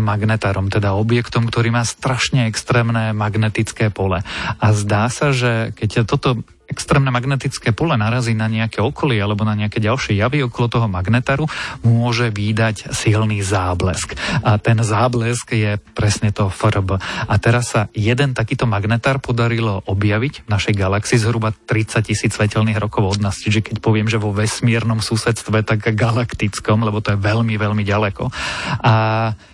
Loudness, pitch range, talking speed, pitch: -18 LUFS, 105-120 Hz, 150 wpm, 110 Hz